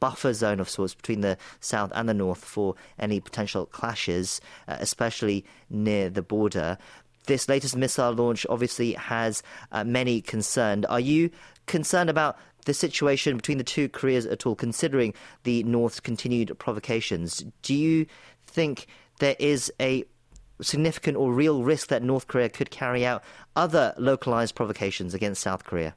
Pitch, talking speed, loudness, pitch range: 120 Hz, 155 wpm, -26 LUFS, 105-135 Hz